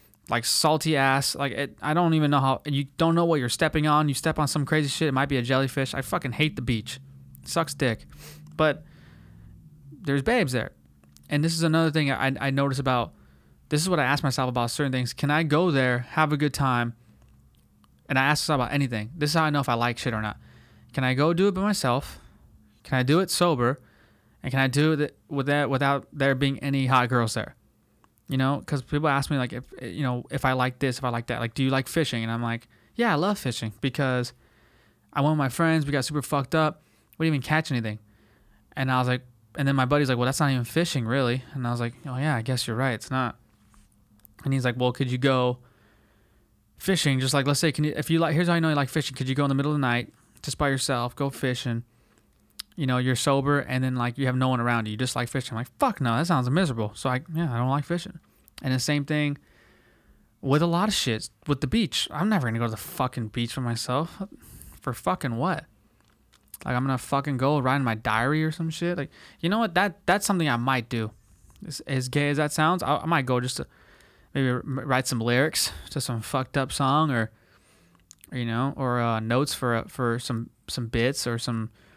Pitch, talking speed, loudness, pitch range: 135 Hz, 245 wpm, -25 LUFS, 120-150 Hz